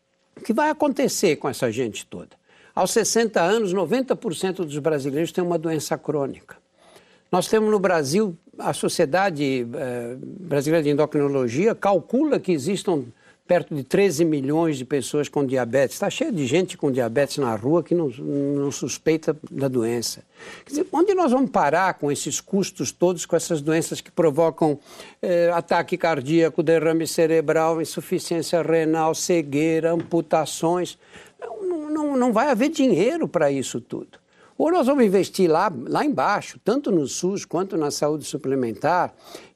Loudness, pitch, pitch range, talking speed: -22 LUFS, 165 Hz, 150-190 Hz, 150 wpm